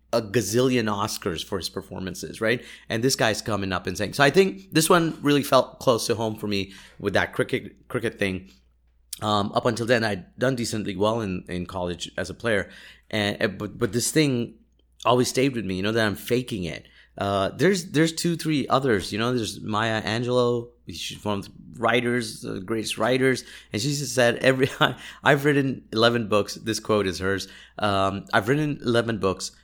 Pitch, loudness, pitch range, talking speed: 110 Hz, -24 LUFS, 100-125 Hz, 195 wpm